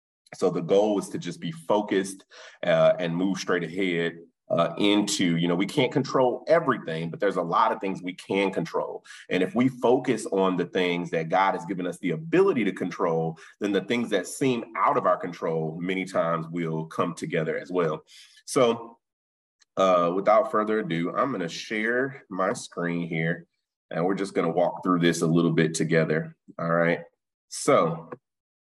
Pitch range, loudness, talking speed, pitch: 80-105 Hz, -25 LUFS, 185 wpm, 85 Hz